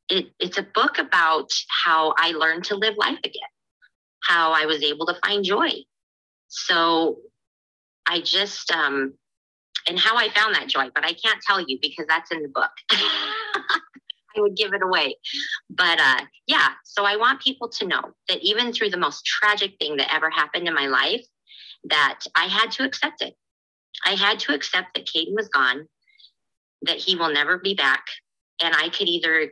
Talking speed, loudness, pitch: 185 wpm, -21 LUFS, 205 Hz